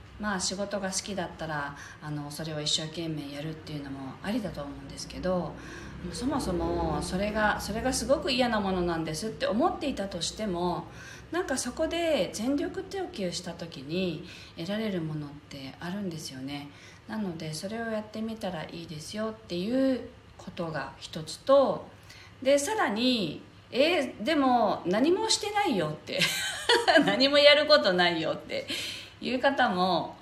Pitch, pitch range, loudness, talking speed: 190 Hz, 160-265 Hz, -28 LUFS, 315 characters per minute